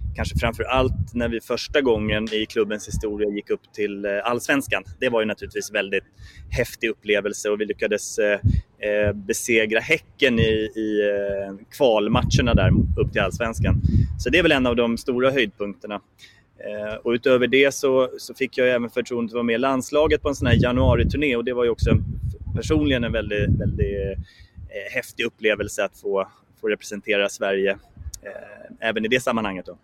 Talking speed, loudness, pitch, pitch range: 160 wpm, -22 LUFS, 110 Hz, 100-125 Hz